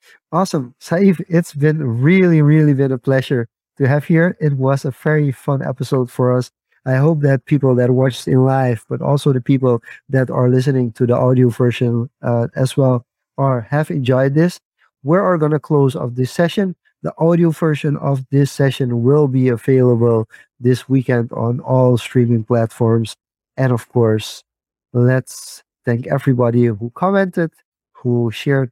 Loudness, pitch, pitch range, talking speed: -16 LUFS, 135 Hz, 125-150 Hz, 165 wpm